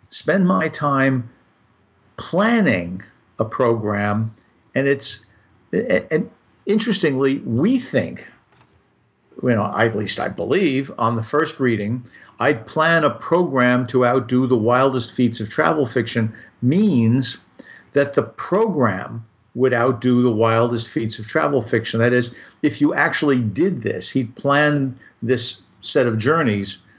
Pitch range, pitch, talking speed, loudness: 110-140 Hz, 125 Hz, 135 wpm, -19 LUFS